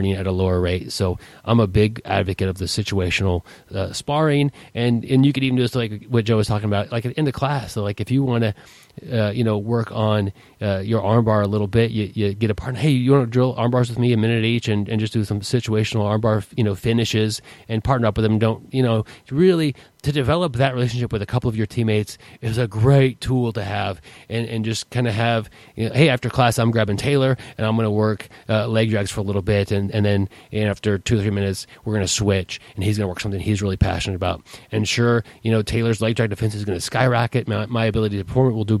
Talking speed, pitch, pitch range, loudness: 260 wpm, 110 Hz, 105-120 Hz, -21 LUFS